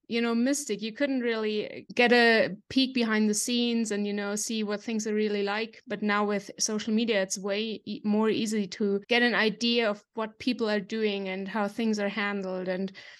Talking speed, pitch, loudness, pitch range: 210 wpm, 215 Hz, -27 LUFS, 205-230 Hz